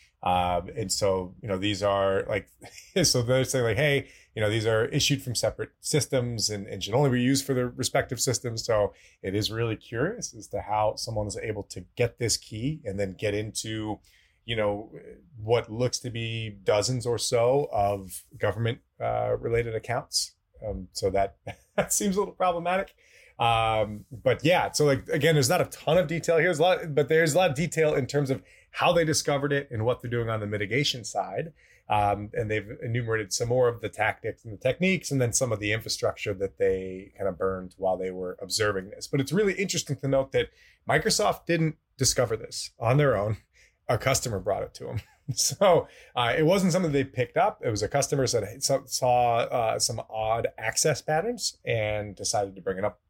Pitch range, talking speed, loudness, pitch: 105-145 Hz, 205 wpm, -27 LUFS, 120 Hz